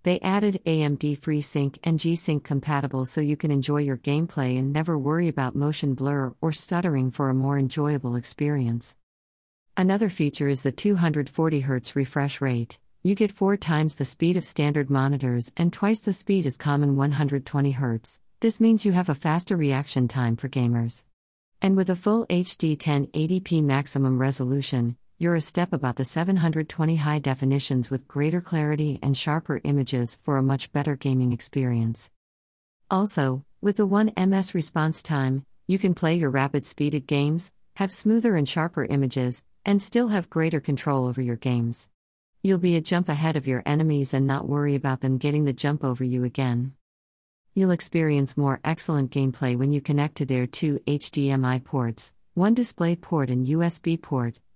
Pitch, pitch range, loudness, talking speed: 145 Hz, 130-165 Hz, -25 LUFS, 165 wpm